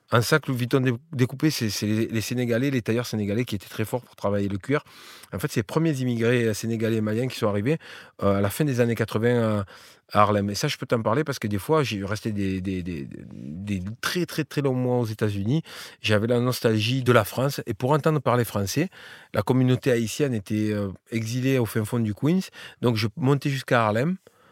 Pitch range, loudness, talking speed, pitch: 105-135 Hz, -25 LUFS, 220 wpm, 120 Hz